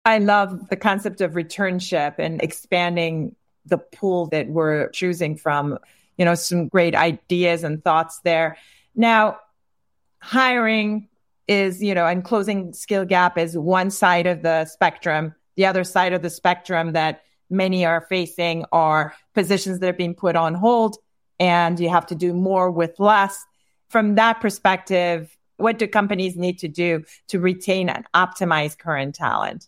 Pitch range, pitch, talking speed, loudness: 165-195 Hz, 180 Hz, 160 wpm, -20 LUFS